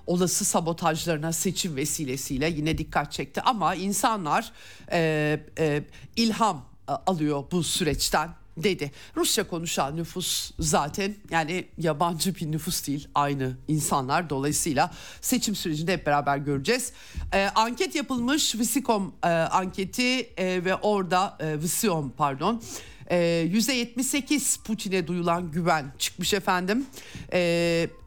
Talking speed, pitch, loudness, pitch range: 115 wpm, 175 Hz, -26 LUFS, 155-205 Hz